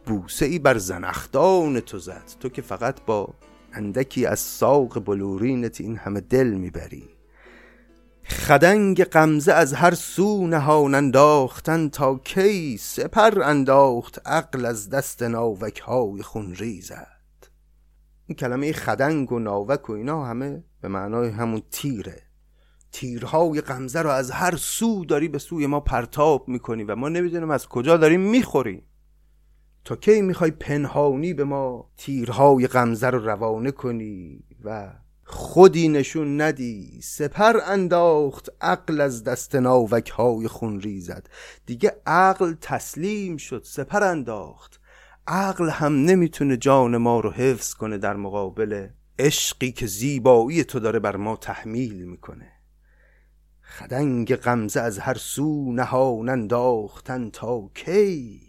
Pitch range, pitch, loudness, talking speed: 110-150 Hz, 130 Hz, -21 LUFS, 130 wpm